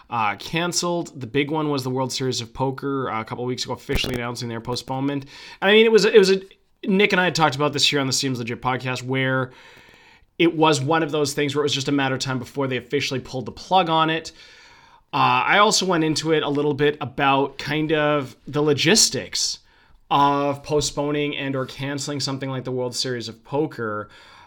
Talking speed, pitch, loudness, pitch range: 225 wpm, 140 Hz, -21 LUFS, 130-155 Hz